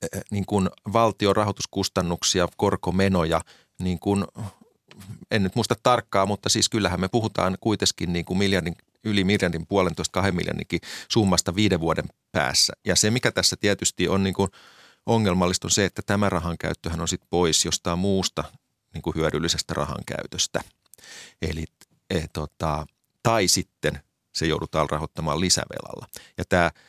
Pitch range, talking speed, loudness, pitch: 85-105 Hz, 145 wpm, -24 LUFS, 95 Hz